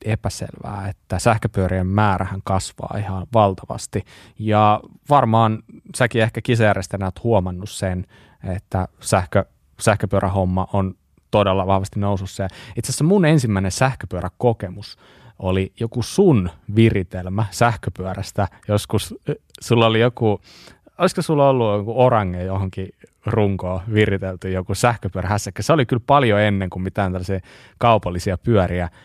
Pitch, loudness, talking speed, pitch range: 105 Hz, -20 LUFS, 120 wpm, 95-115 Hz